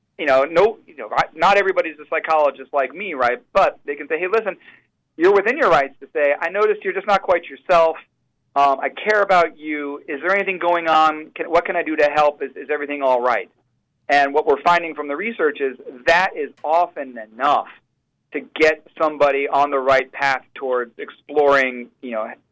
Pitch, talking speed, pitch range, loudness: 155 Hz, 205 wpm, 140-175 Hz, -19 LUFS